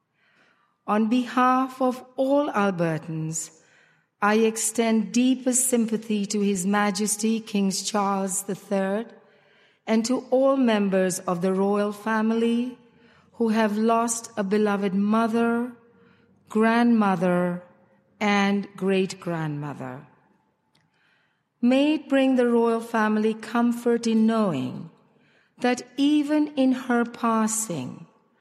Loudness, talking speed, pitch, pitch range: -23 LUFS, 100 wpm, 220 Hz, 200-235 Hz